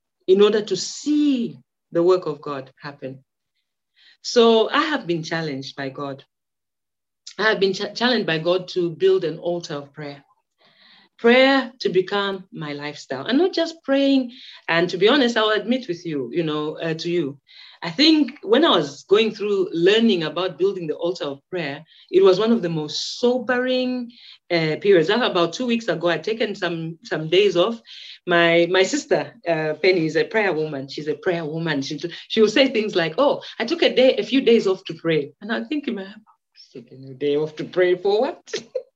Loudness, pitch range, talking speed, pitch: -20 LUFS, 155-235 Hz, 195 wpm, 185 Hz